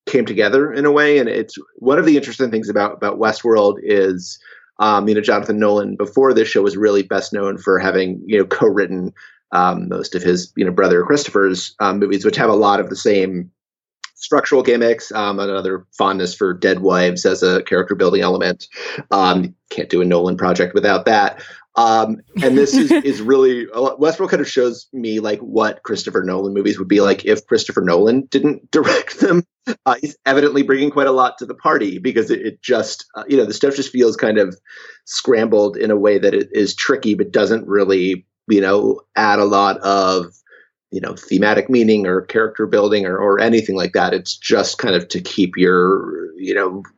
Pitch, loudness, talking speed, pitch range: 105 Hz, -16 LUFS, 205 wpm, 95-135 Hz